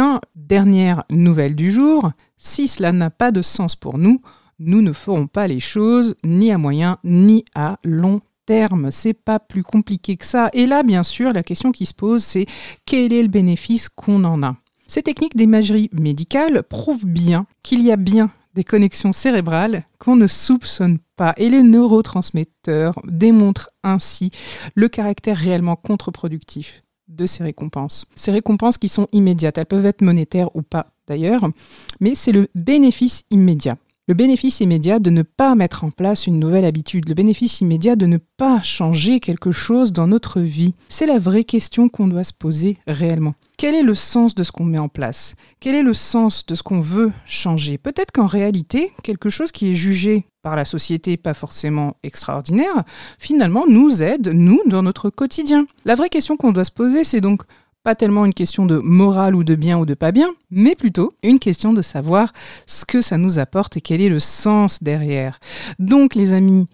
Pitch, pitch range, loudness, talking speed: 195 Hz, 170-230 Hz, -16 LUFS, 190 wpm